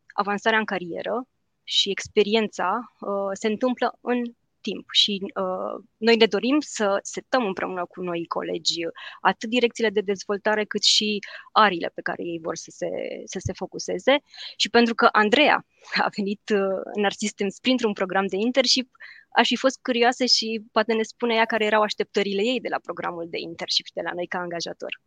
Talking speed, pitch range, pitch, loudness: 180 wpm, 195-235 Hz, 215 Hz, -23 LUFS